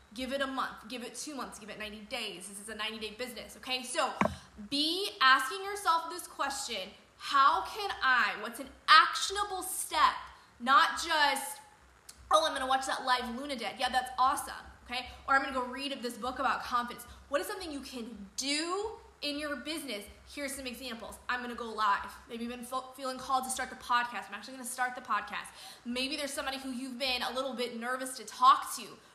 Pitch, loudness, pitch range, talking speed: 260 Hz, -32 LUFS, 240-285 Hz, 205 wpm